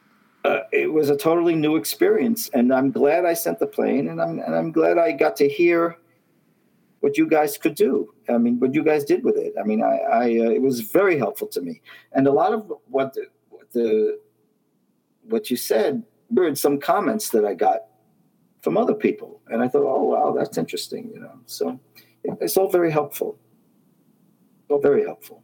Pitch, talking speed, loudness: 180 Hz, 200 wpm, -21 LUFS